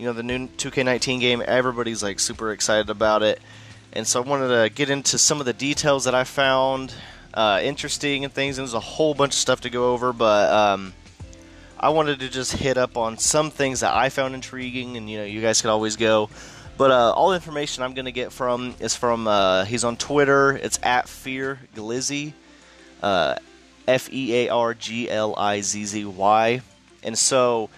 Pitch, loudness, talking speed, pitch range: 125 Hz, -21 LUFS, 185 wpm, 110-135 Hz